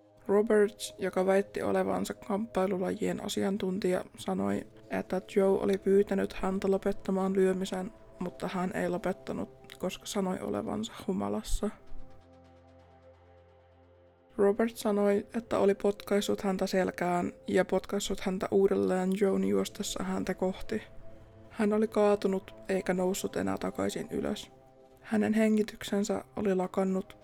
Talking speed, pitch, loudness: 110 wpm, 185 Hz, -31 LUFS